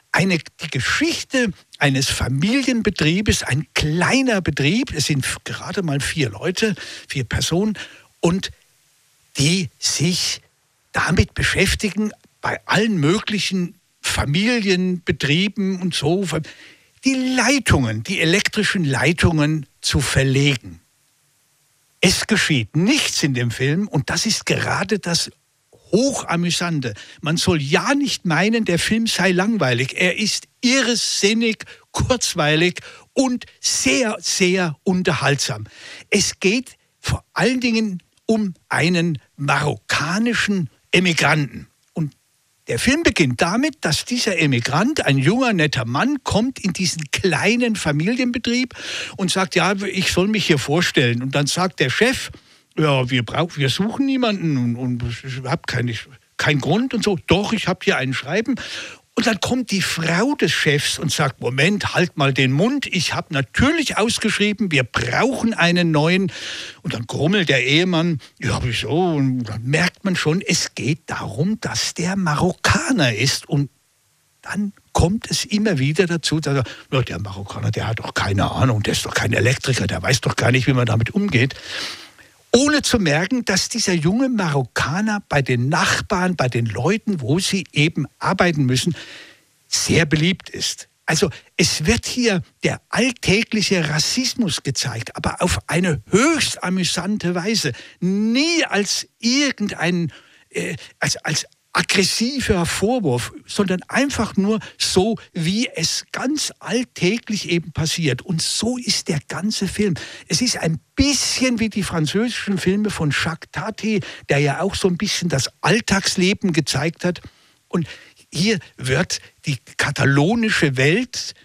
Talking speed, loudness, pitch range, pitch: 140 wpm, -19 LUFS, 140-210 Hz, 175 Hz